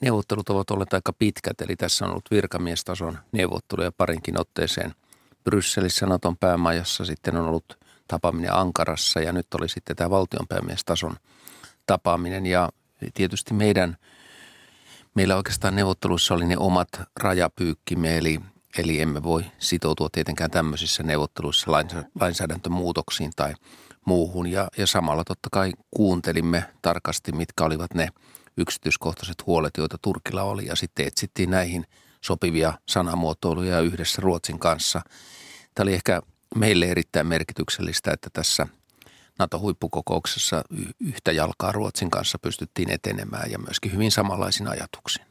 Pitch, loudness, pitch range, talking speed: 90 Hz, -25 LUFS, 80-95 Hz, 125 wpm